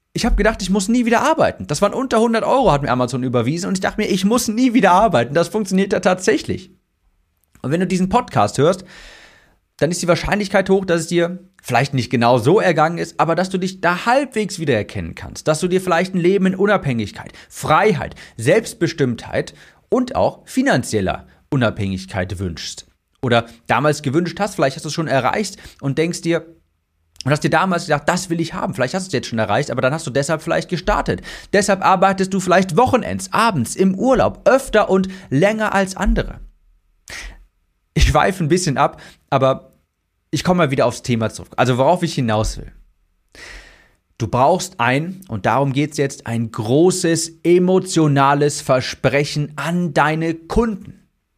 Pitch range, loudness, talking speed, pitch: 130-190 Hz, -18 LUFS, 180 wpm, 165 Hz